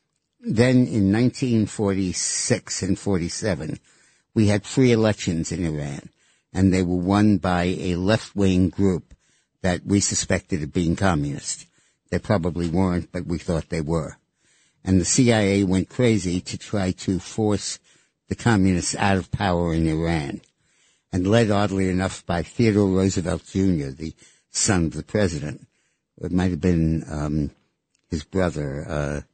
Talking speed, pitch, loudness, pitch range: 145 wpm, 95 Hz, -22 LUFS, 85-100 Hz